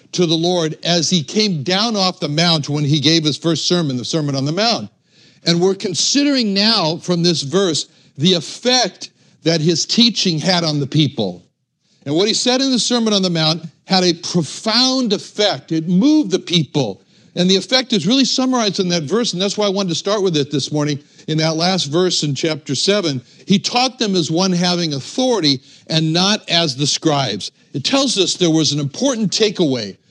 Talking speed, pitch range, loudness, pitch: 205 wpm, 155-205 Hz, -16 LUFS, 175 Hz